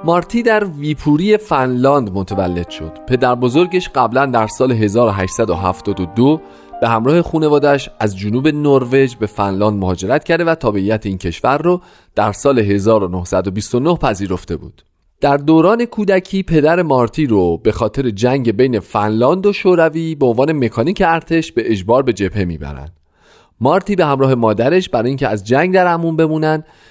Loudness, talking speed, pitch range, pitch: -15 LUFS, 145 wpm, 105-160 Hz, 130 Hz